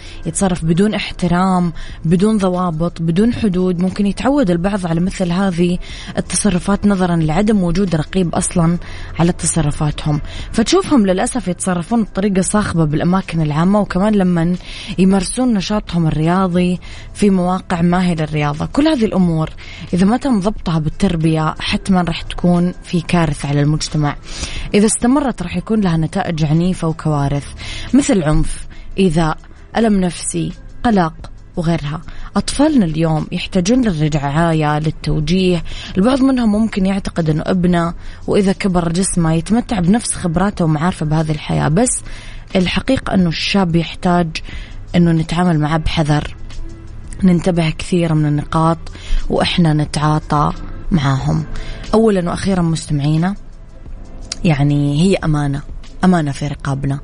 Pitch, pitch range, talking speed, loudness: 175 Hz, 155-195 Hz, 120 wpm, -16 LUFS